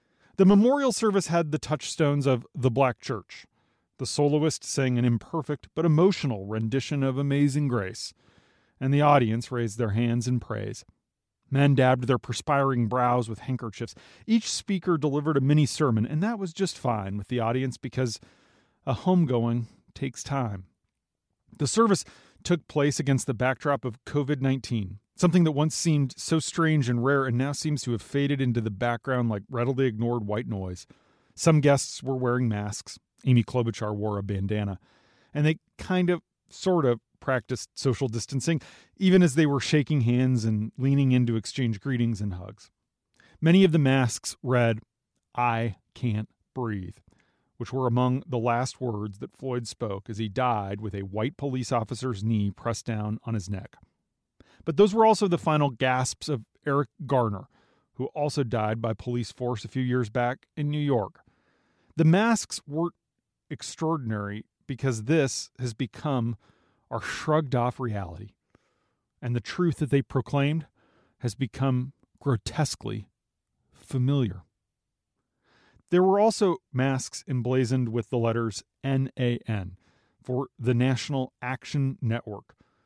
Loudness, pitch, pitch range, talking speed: -26 LUFS, 125 Hz, 115-145 Hz, 150 wpm